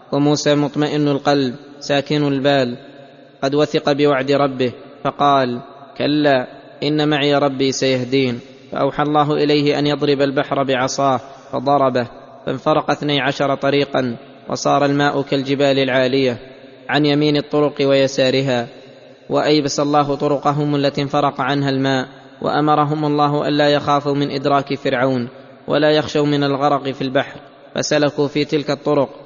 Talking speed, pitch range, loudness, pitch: 120 wpm, 135-145 Hz, -17 LUFS, 140 Hz